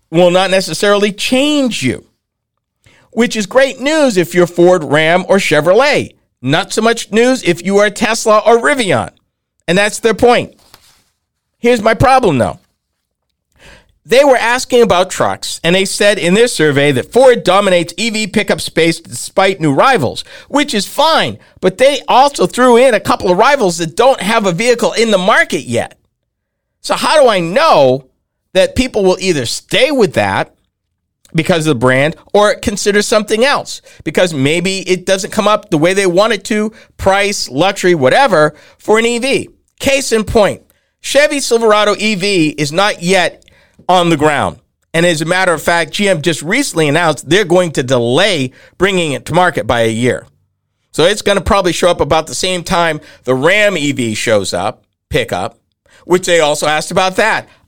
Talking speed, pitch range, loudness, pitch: 175 wpm, 160-220 Hz, -12 LUFS, 190 Hz